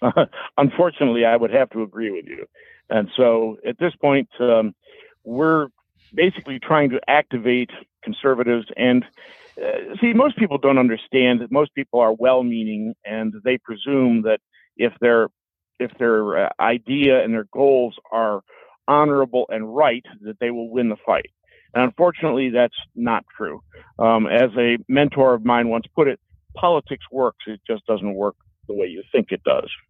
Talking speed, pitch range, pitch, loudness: 165 wpm, 115-145 Hz, 125 Hz, -20 LUFS